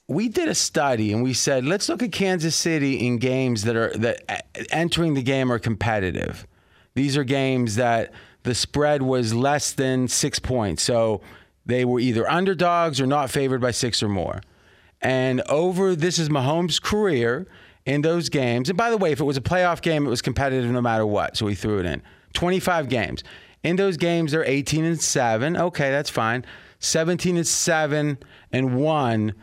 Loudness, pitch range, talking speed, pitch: -22 LUFS, 115-160 Hz, 190 wpm, 135 Hz